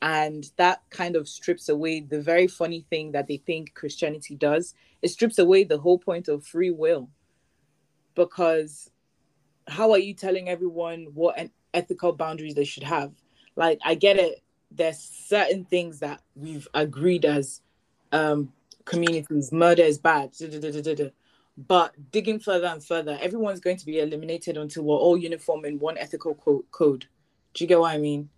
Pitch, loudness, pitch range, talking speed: 165 Hz, -24 LUFS, 150-180 Hz, 180 wpm